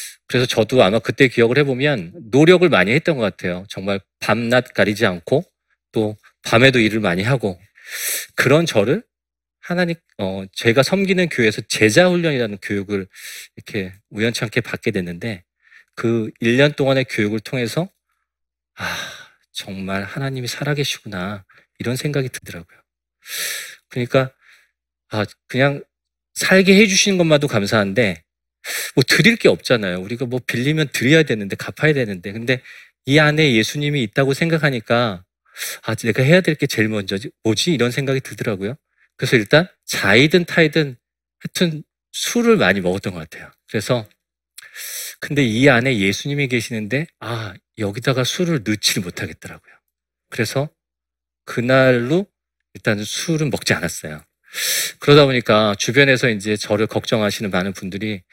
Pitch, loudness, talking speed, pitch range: 120 Hz, -18 LUFS, 315 characters per minute, 100-140 Hz